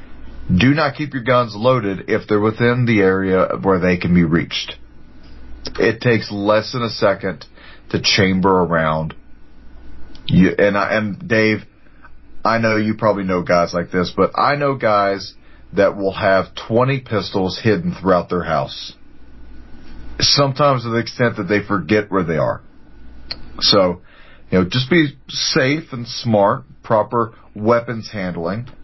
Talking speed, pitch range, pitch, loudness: 150 wpm, 90-120 Hz, 105 Hz, -17 LUFS